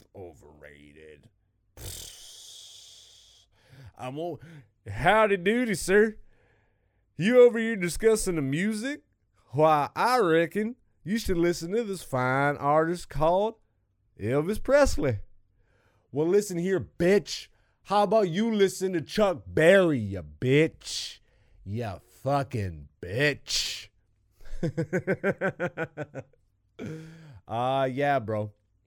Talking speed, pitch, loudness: 90 wpm, 140 Hz, -26 LUFS